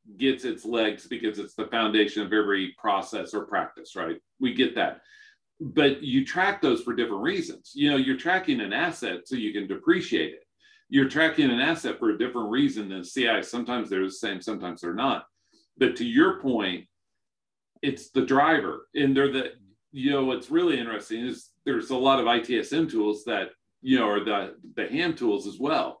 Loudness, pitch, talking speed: -26 LUFS, 140 Hz, 190 wpm